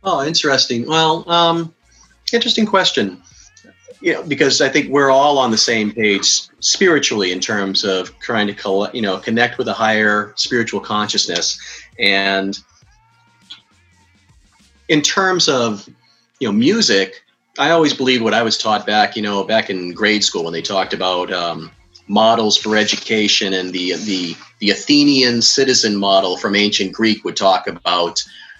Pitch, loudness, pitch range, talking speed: 105 Hz, -15 LUFS, 95-130 Hz, 155 wpm